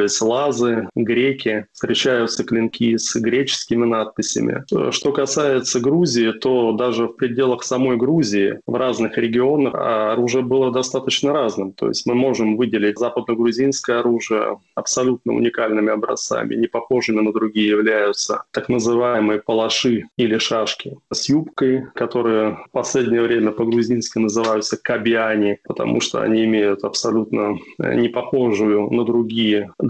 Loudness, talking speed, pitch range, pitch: -19 LUFS, 120 wpm, 110-125 Hz, 115 Hz